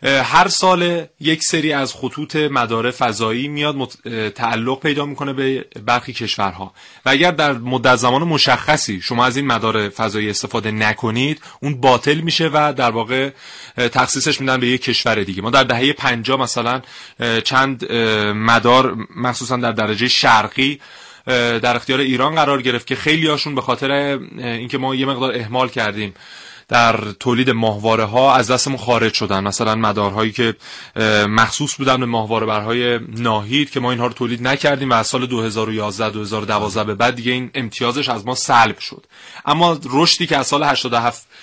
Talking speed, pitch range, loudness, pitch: 160 wpm, 115-135 Hz, -16 LUFS, 125 Hz